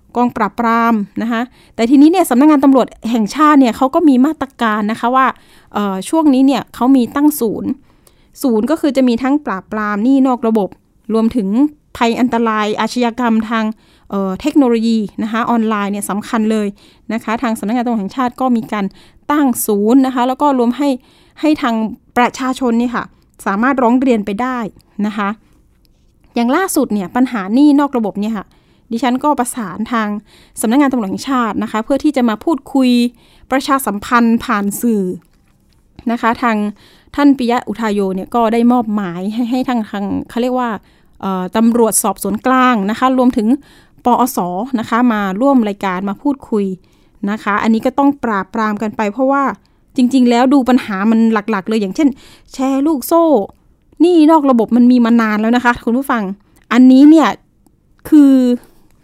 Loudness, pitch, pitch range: -14 LUFS, 235 Hz, 215-260 Hz